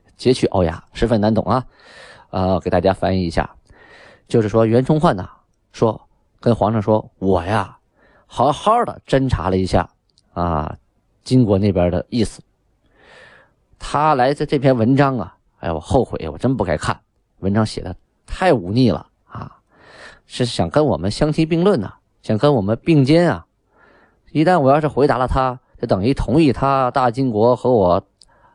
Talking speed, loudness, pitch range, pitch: 240 characters per minute, -18 LUFS, 95-135 Hz, 115 Hz